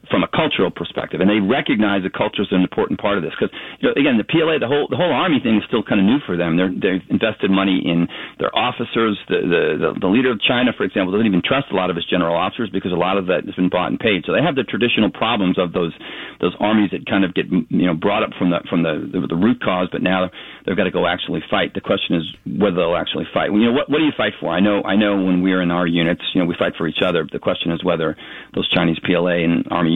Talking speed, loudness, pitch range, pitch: 285 wpm, -18 LUFS, 85-100 Hz, 90 Hz